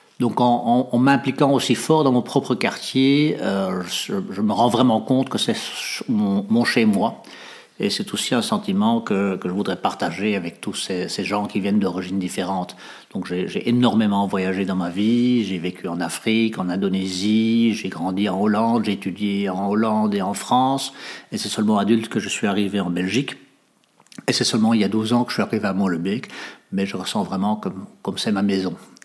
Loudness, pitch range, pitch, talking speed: -21 LUFS, 100-130 Hz, 110 Hz, 210 wpm